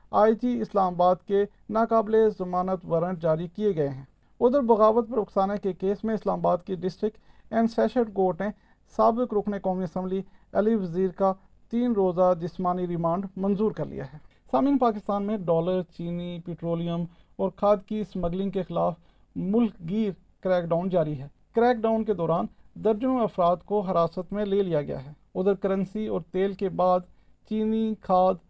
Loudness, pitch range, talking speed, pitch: -26 LUFS, 180-215 Hz, 170 wpm, 195 Hz